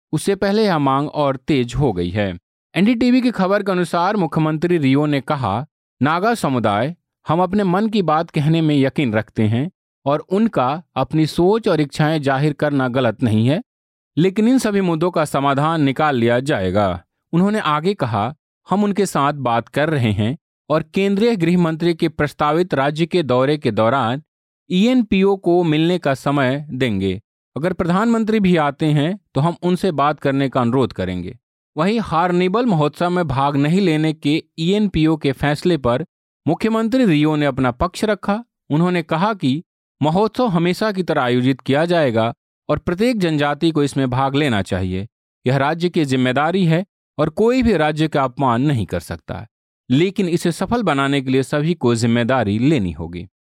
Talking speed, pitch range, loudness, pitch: 170 wpm, 130-180 Hz, -18 LUFS, 155 Hz